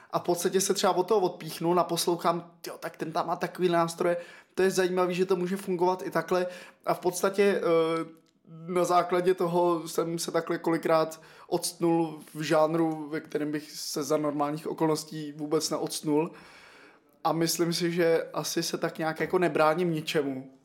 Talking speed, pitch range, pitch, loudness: 170 wpm, 160-175 Hz, 170 Hz, -28 LUFS